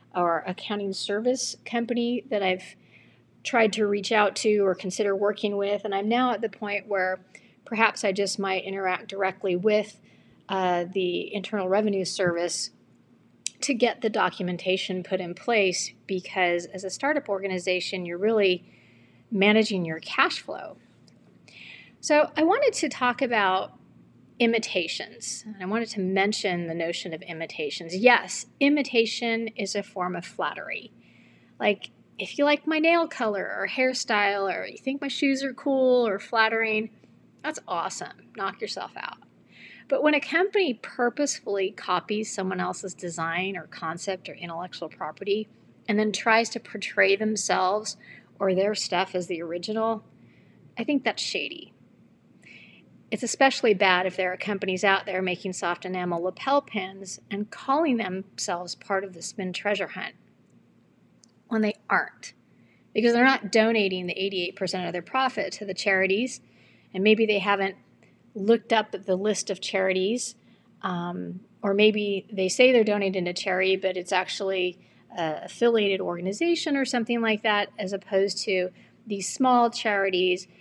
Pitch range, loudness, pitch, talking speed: 185-230 Hz, -26 LUFS, 200 Hz, 150 wpm